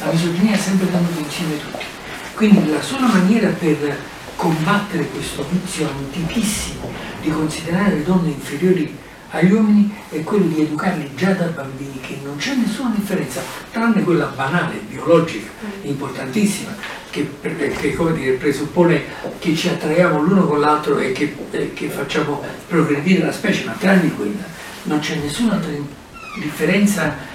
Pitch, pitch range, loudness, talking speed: 170 Hz, 150-195 Hz, -19 LUFS, 145 wpm